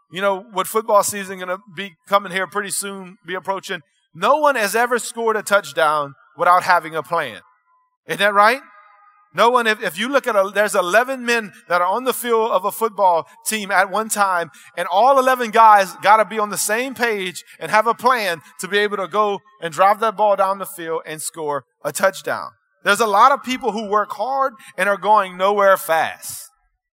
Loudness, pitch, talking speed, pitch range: -18 LUFS, 205 Hz, 205 wpm, 185-225 Hz